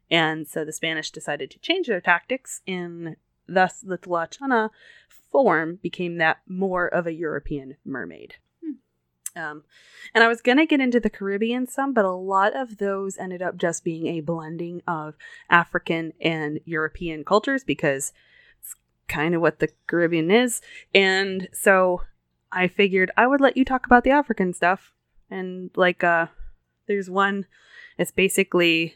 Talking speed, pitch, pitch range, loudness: 160 wpm, 180 Hz, 165-205 Hz, -22 LUFS